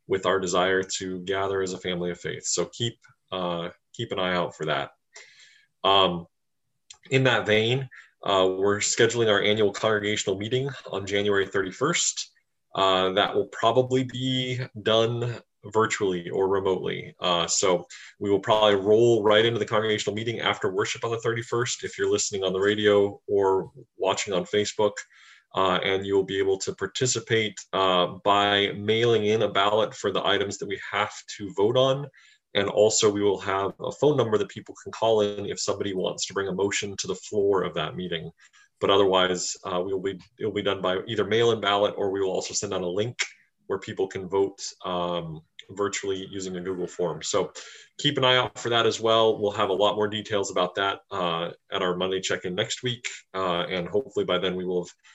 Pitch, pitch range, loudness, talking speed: 100 Hz, 95-110 Hz, -25 LUFS, 200 wpm